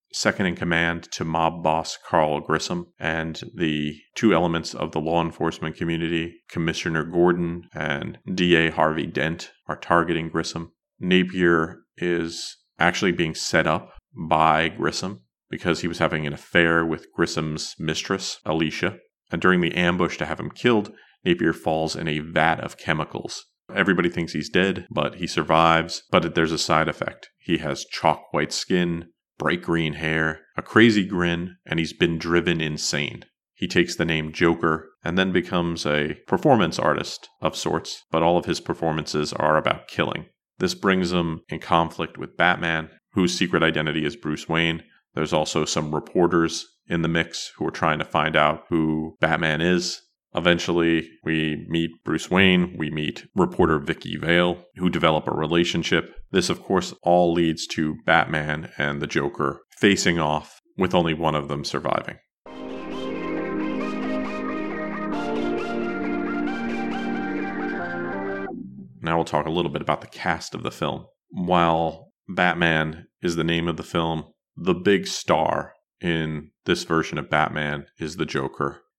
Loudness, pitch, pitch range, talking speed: -23 LUFS, 80 Hz, 80-85 Hz, 150 wpm